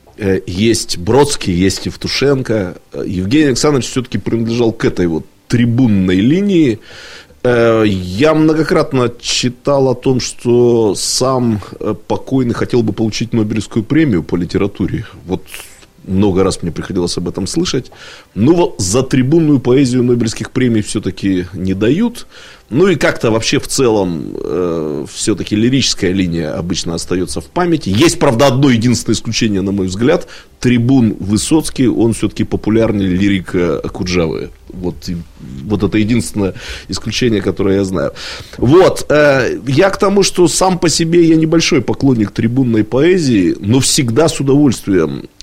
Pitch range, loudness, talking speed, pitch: 95-135 Hz, -13 LUFS, 135 wpm, 115 Hz